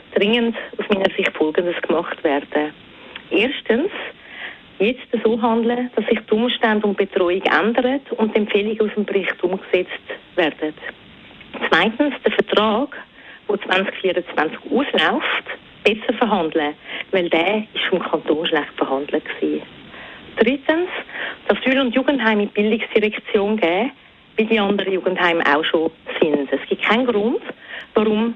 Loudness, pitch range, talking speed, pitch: -19 LUFS, 180-235 Hz, 130 wpm, 210 Hz